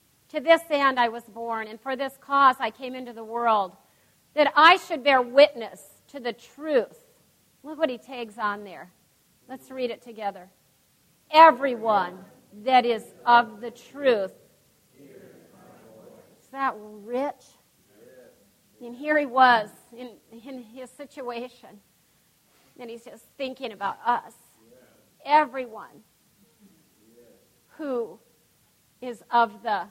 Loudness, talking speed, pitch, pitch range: -23 LUFS, 120 wpm, 245 Hz, 230-275 Hz